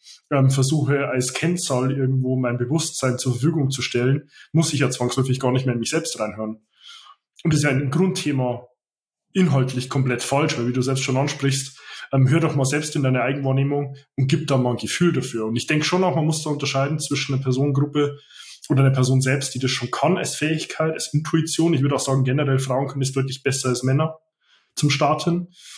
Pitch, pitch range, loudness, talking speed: 135 Hz, 130-150 Hz, -21 LUFS, 205 wpm